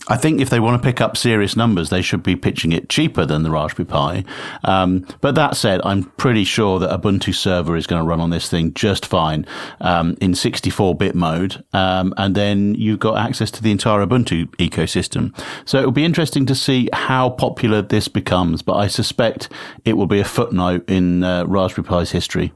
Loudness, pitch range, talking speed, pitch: -17 LUFS, 90-115 Hz, 210 wpm, 100 Hz